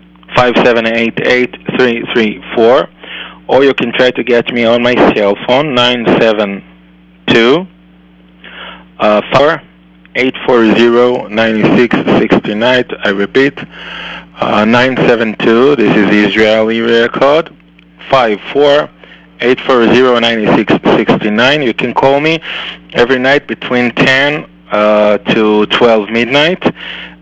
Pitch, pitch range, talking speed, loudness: 115 Hz, 100-125 Hz, 140 wpm, -10 LUFS